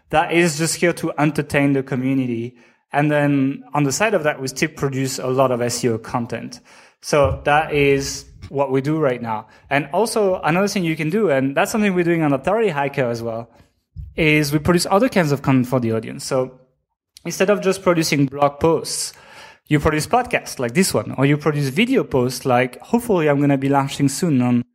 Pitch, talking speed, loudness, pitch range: 145 Hz, 205 wpm, -19 LUFS, 130-165 Hz